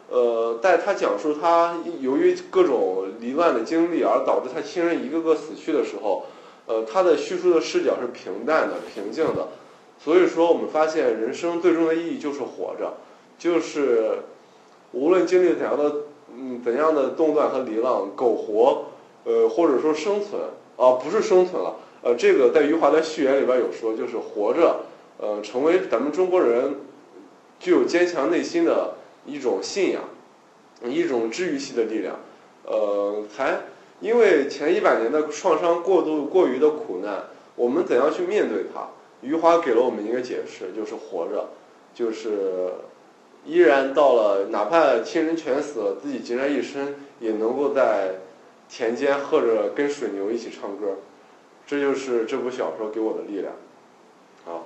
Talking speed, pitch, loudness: 250 characters per minute, 185 Hz, -22 LUFS